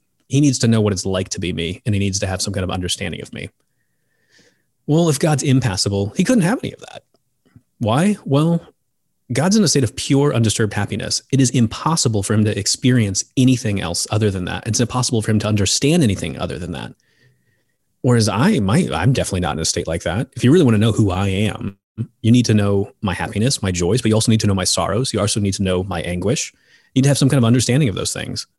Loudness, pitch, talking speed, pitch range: -18 LUFS, 110 Hz, 245 wpm, 100-130 Hz